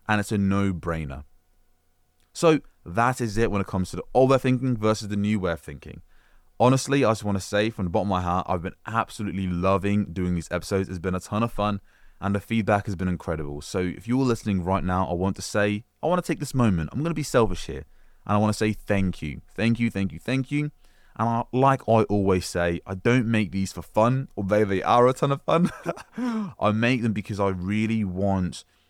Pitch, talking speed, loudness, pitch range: 100 Hz, 240 wpm, -25 LUFS, 90-115 Hz